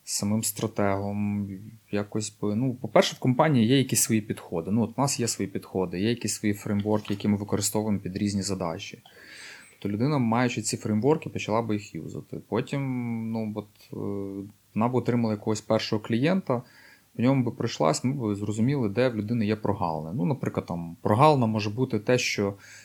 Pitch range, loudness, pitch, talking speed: 100-125 Hz, -27 LUFS, 110 Hz, 175 wpm